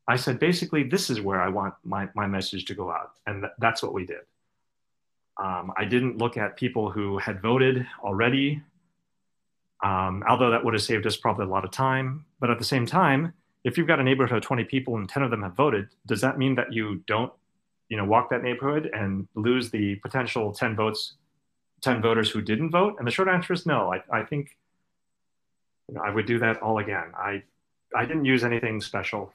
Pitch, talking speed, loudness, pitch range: 120 Hz, 215 wpm, -26 LUFS, 110-140 Hz